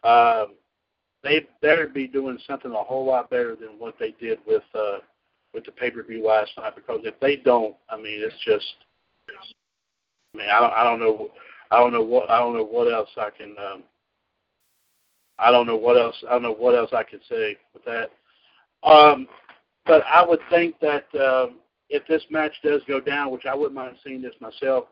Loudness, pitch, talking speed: -21 LUFS, 145 Hz, 210 wpm